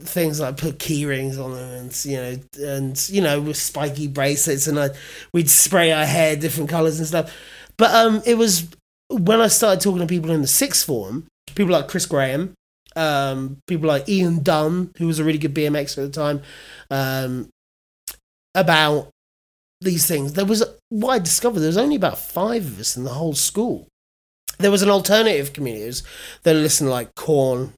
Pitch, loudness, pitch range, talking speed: 155 Hz, -19 LUFS, 140-180 Hz, 195 wpm